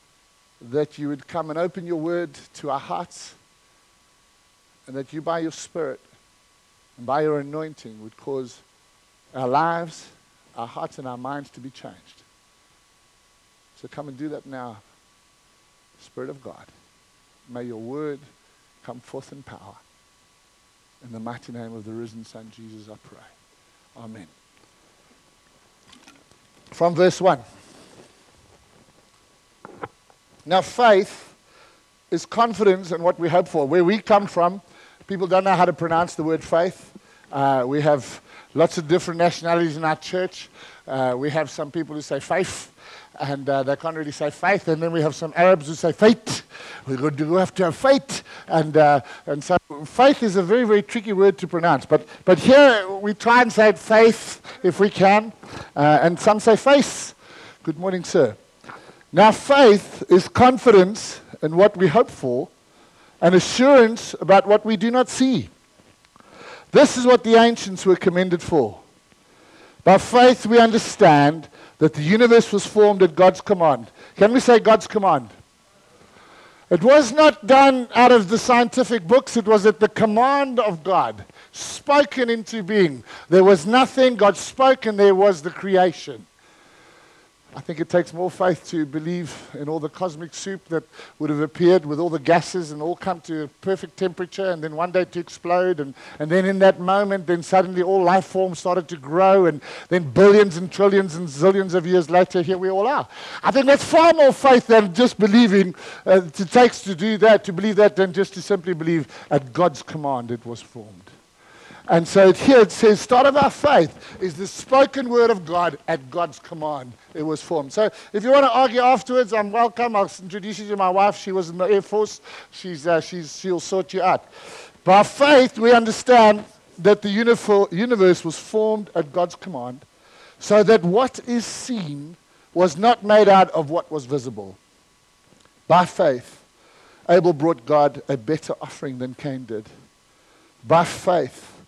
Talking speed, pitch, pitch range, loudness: 170 wpm, 180 Hz, 155-210 Hz, -18 LUFS